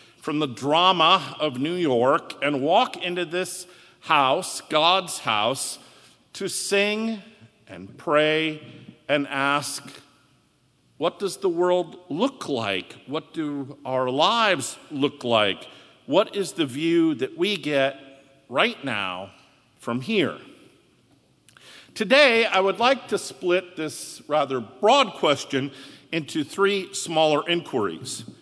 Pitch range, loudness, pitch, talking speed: 140-190 Hz, -23 LUFS, 155 Hz, 120 wpm